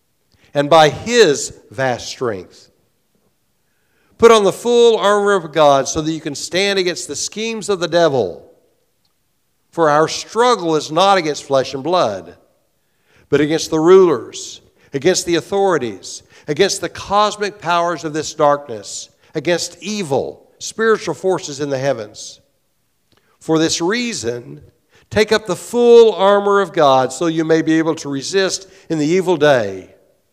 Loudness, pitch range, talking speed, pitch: -15 LUFS, 150-205 Hz, 145 wpm, 175 Hz